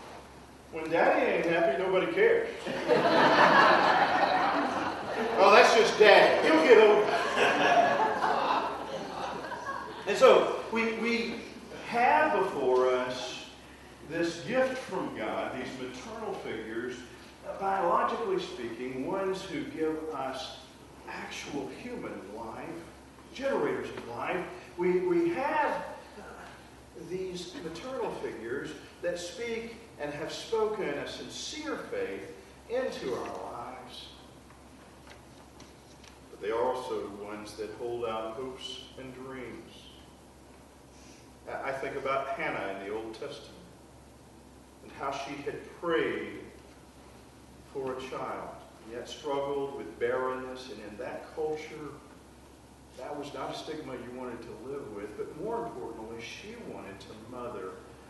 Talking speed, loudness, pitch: 115 wpm, -29 LUFS, 150 Hz